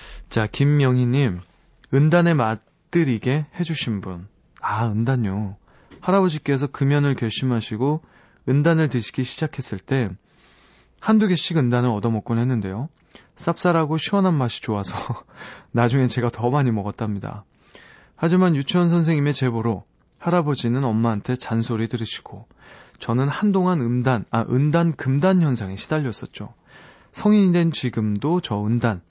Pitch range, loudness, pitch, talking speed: 115-160 Hz, -21 LUFS, 130 Hz, 295 characters per minute